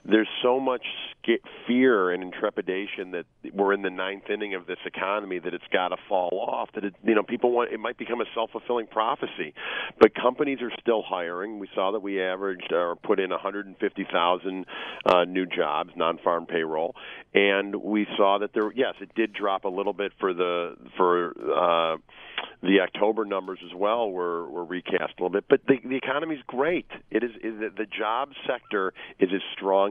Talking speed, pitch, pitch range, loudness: 195 wpm, 100 Hz, 95-115 Hz, -26 LUFS